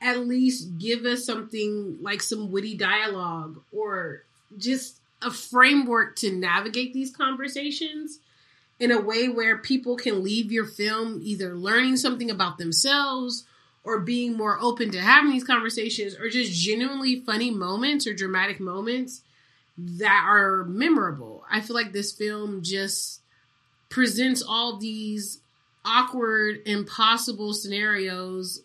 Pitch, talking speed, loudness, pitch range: 220 Hz, 130 wpm, -24 LUFS, 200-250 Hz